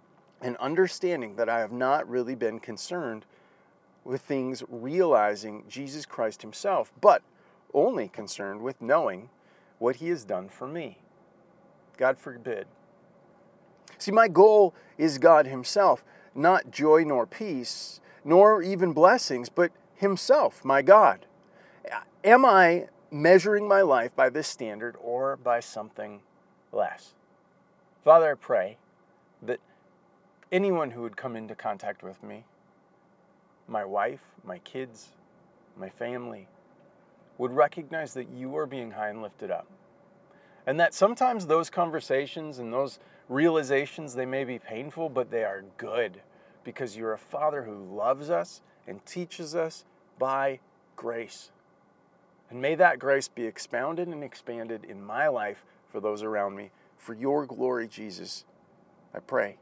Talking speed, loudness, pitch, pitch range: 135 wpm, -26 LUFS, 135 Hz, 120-180 Hz